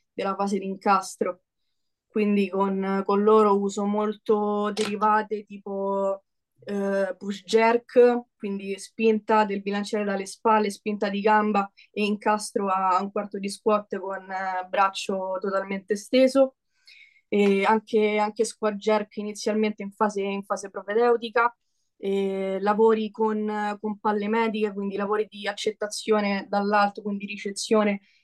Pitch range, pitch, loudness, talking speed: 200-215 Hz, 210 Hz, -25 LUFS, 125 wpm